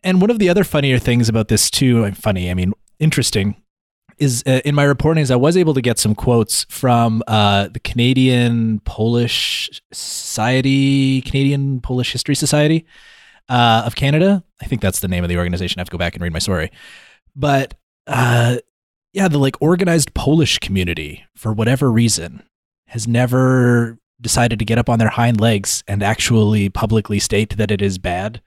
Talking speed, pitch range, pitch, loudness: 180 wpm, 105-135 Hz, 120 Hz, -16 LUFS